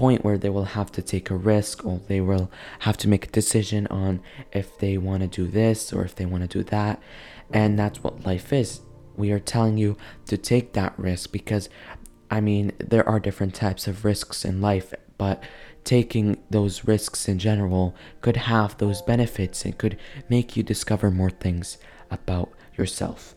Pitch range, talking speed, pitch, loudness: 95-110 Hz, 190 wpm, 105 Hz, -25 LUFS